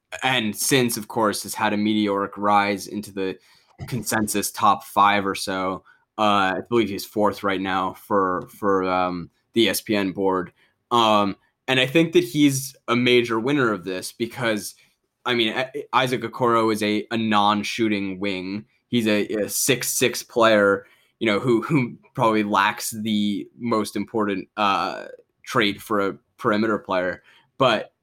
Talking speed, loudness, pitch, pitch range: 150 wpm, -22 LUFS, 105 Hz, 100-115 Hz